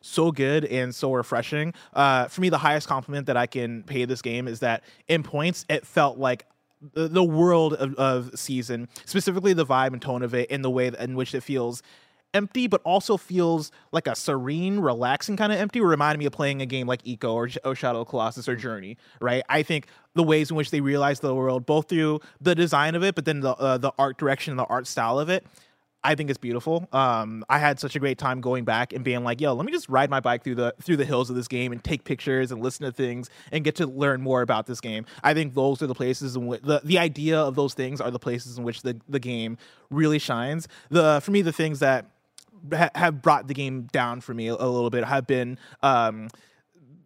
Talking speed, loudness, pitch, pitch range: 240 wpm, -25 LUFS, 135 Hz, 125-155 Hz